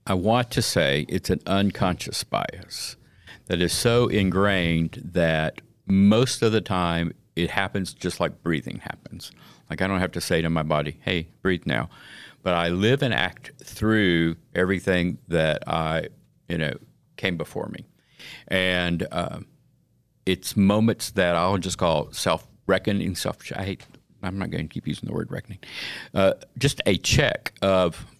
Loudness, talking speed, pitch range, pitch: -24 LUFS, 160 wpm, 85-100 Hz, 90 Hz